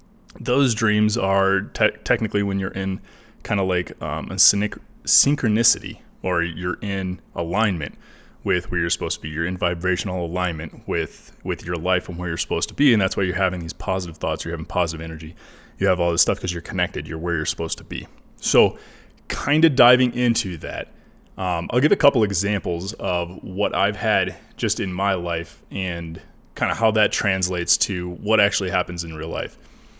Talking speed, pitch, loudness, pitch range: 195 wpm, 90 Hz, -21 LUFS, 85-100 Hz